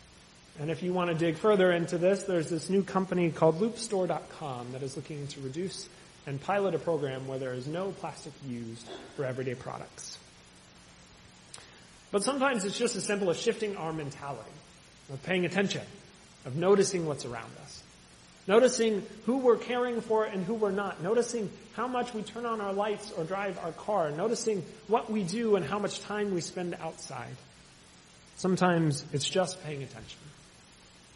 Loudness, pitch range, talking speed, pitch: -31 LUFS, 145-205 Hz, 170 wpm, 180 Hz